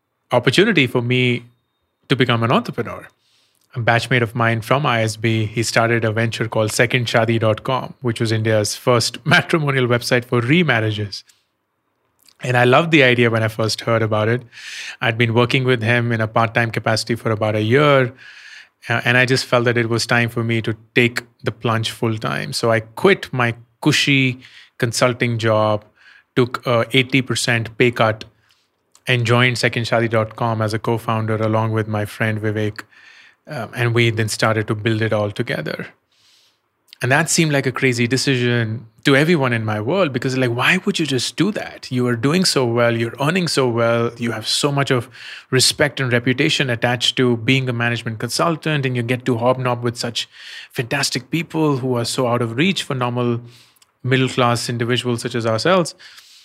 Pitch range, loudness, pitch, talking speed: 115-130 Hz, -18 LUFS, 120 Hz, 180 wpm